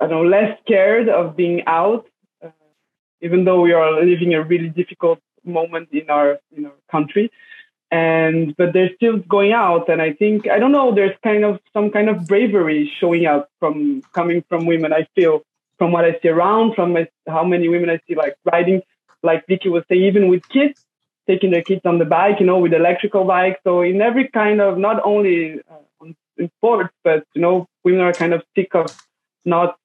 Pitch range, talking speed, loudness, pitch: 165-205 Hz, 205 wpm, -16 LUFS, 180 Hz